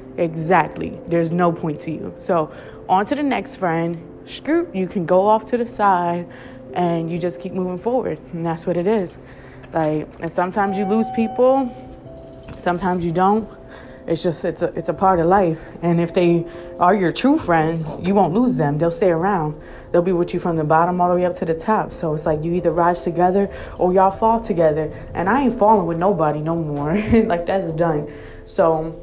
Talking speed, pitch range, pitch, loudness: 205 wpm, 165-195 Hz, 175 Hz, -19 LUFS